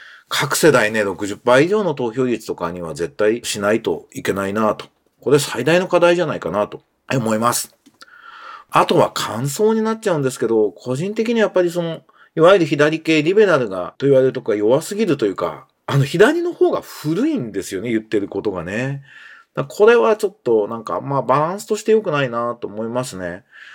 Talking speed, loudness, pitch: 370 characters per minute, -18 LUFS, 145 Hz